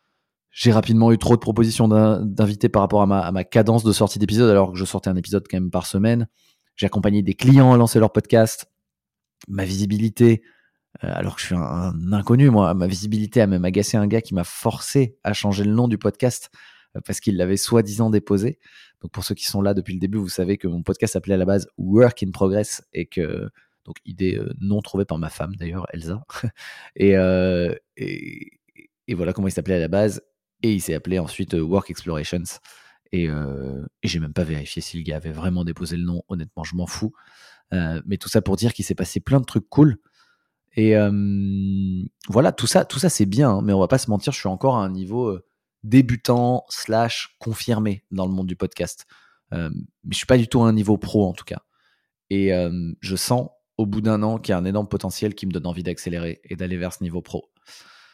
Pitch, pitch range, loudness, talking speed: 100 Hz, 90-110 Hz, -21 LUFS, 225 wpm